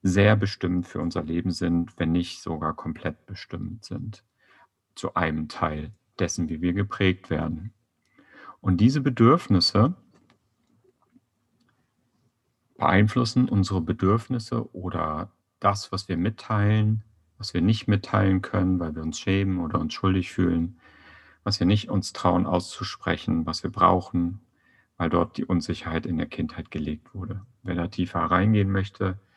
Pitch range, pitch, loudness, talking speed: 85-105 Hz, 95 Hz, -25 LUFS, 135 wpm